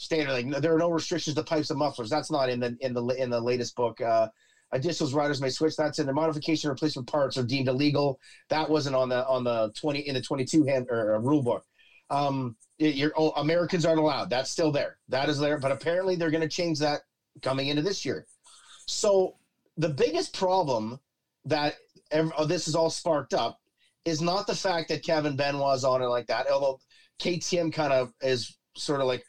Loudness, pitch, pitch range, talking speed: -28 LUFS, 150 Hz, 130-160 Hz, 215 wpm